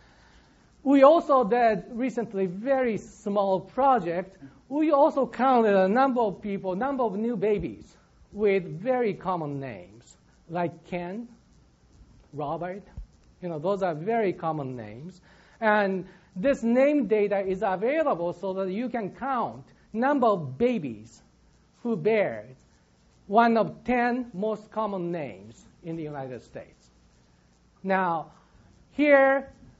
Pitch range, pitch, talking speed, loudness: 175-240 Hz, 205 Hz, 120 wpm, -26 LUFS